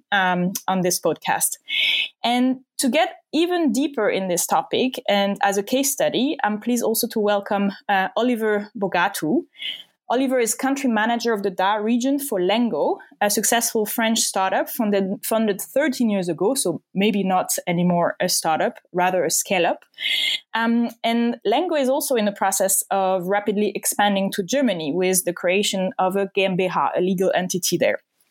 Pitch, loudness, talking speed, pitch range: 210 Hz, -21 LUFS, 165 wpm, 195-255 Hz